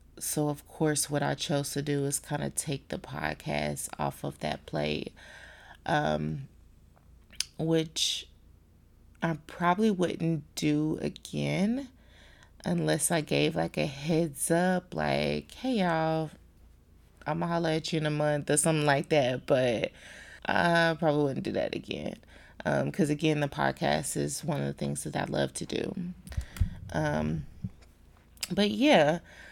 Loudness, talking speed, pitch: -30 LUFS, 145 wpm, 145 Hz